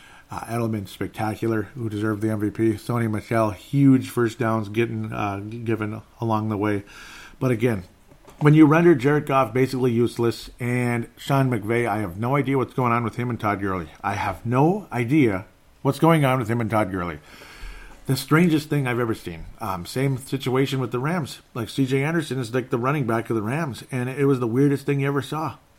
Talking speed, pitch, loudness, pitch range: 200 wpm, 120 Hz, -23 LUFS, 110-135 Hz